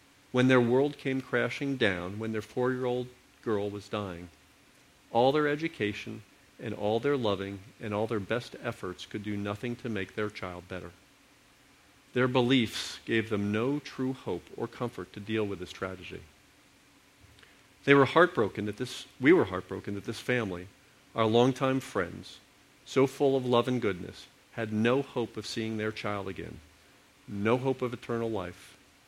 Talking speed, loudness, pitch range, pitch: 165 wpm, -30 LUFS, 105-130 Hz, 115 Hz